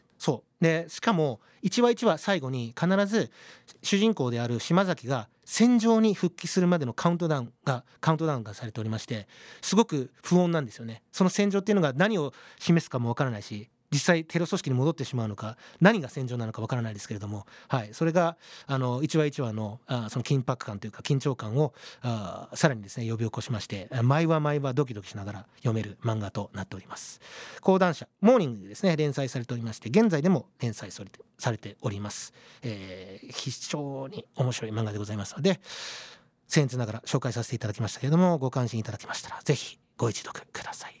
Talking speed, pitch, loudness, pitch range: 425 characters per minute, 130 Hz, -28 LUFS, 115-165 Hz